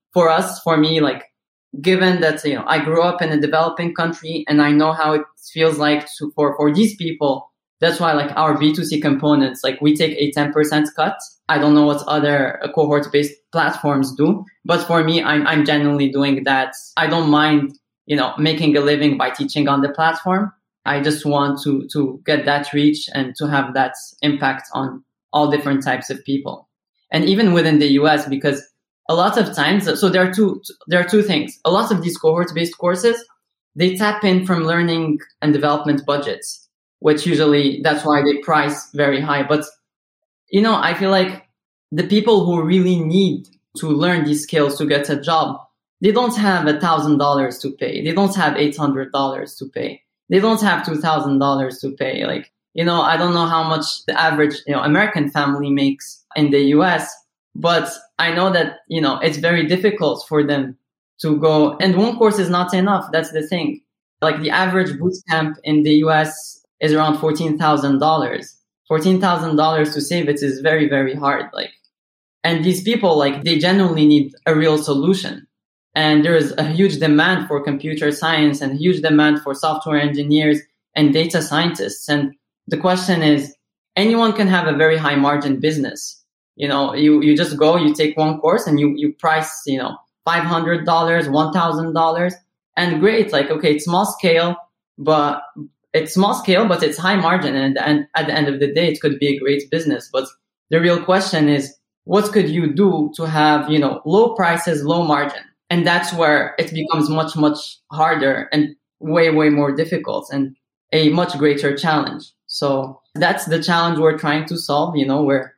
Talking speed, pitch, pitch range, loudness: 190 wpm, 155 Hz, 145-170 Hz, -17 LUFS